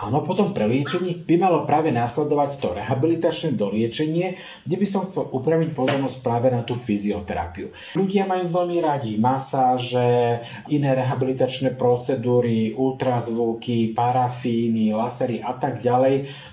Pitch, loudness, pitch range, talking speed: 130 Hz, -22 LUFS, 120-155 Hz, 125 wpm